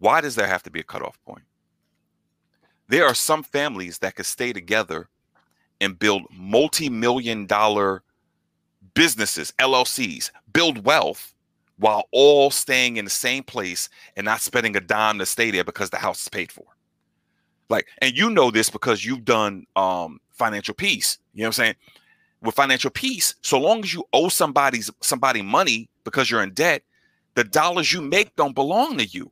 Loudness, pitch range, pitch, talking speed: -21 LUFS, 105-140 Hz, 115 Hz, 175 wpm